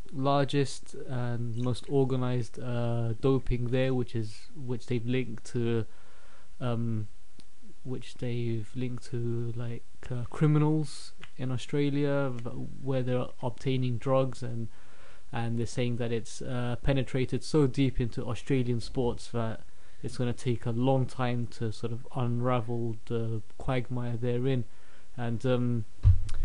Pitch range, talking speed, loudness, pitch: 115-130 Hz, 130 wpm, -31 LUFS, 120 Hz